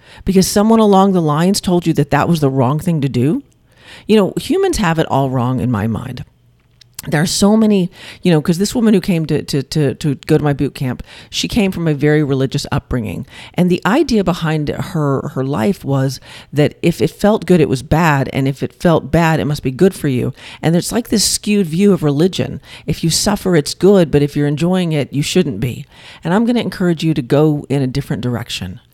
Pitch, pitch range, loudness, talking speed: 155 Hz, 135-185 Hz, -15 LUFS, 230 wpm